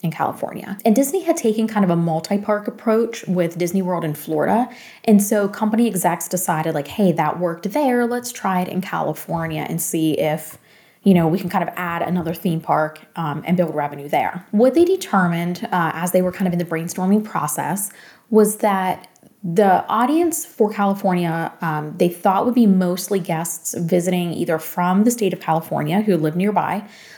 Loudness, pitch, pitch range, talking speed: -20 LUFS, 185 Hz, 170-215 Hz, 190 wpm